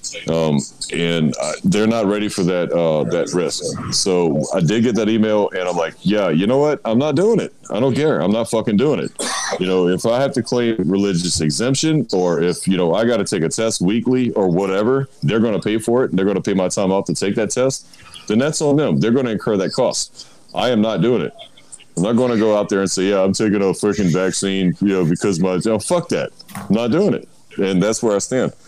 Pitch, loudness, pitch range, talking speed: 105 Hz, -18 LUFS, 90-115 Hz, 255 wpm